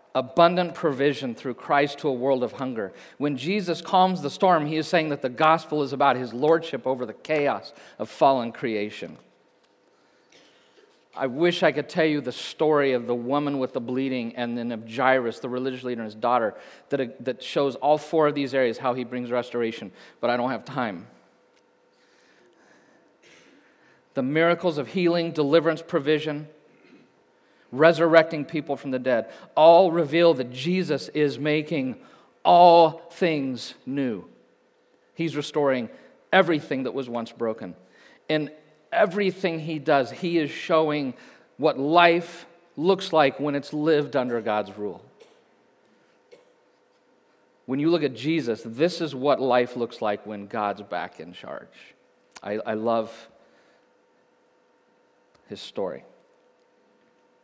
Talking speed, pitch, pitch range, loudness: 140 wpm, 145 Hz, 125-165 Hz, -24 LUFS